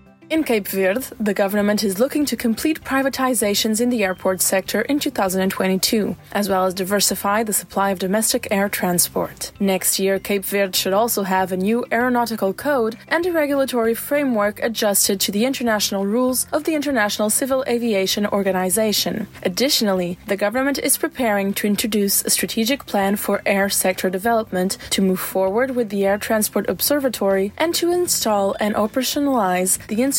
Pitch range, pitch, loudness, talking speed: 195-245 Hz, 210 Hz, -19 LUFS, 160 wpm